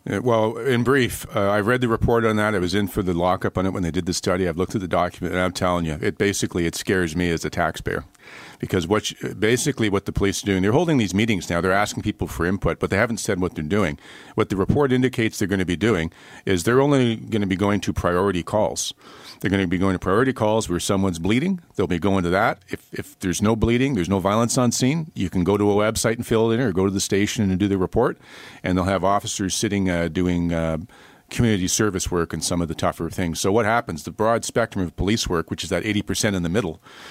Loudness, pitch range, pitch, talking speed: -22 LUFS, 90-115 Hz, 100 Hz, 265 wpm